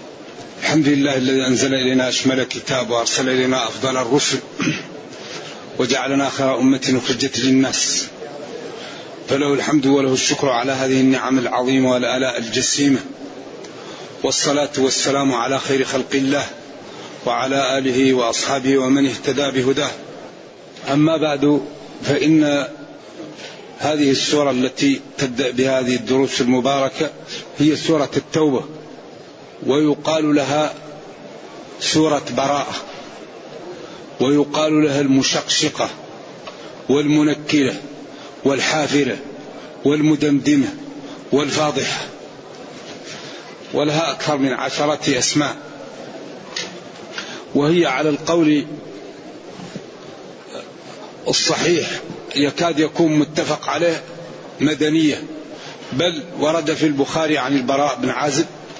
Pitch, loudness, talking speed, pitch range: 140 Hz, -18 LUFS, 85 wpm, 130-150 Hz